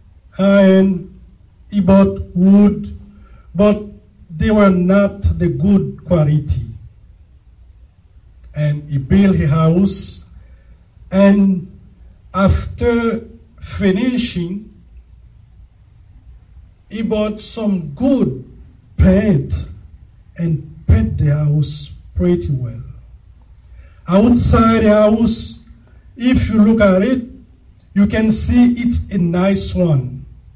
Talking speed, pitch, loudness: 90 wpm, 175 Hz, -15 LUFS